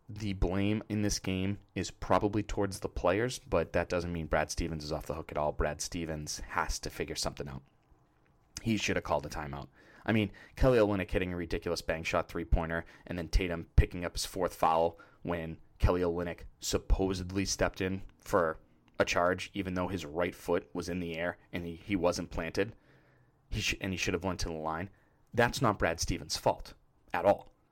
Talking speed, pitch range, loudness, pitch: 205 wpm, 80-100 Hz, -33 LUFS, 90 Hz